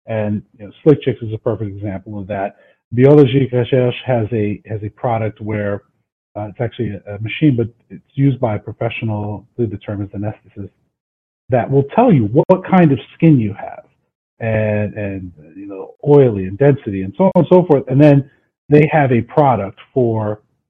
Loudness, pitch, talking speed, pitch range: -16 LUFS, 115 Hz, 185 wpm, 105-135 Hz